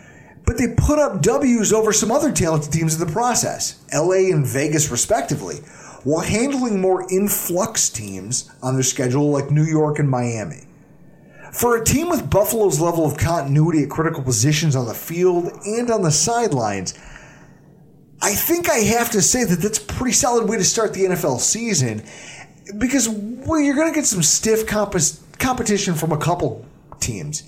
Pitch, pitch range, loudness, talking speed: 175 Hz, 150-220 Hz, -18 LUFS, 175 wpm